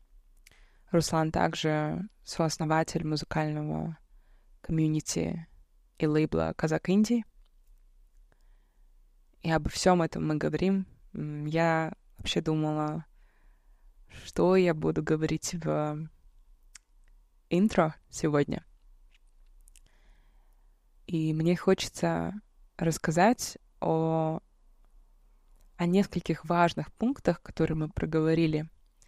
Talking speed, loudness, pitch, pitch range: 75 wpm, -29 LUFS, 160 Hz, 155-175 Hz